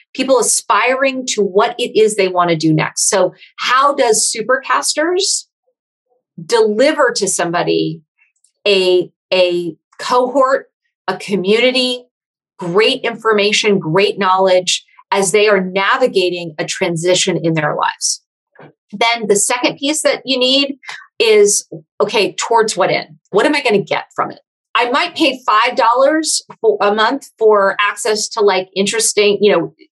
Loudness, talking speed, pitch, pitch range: -14 LUFS, 140 wpm, 215 Hz, 190-260 Hz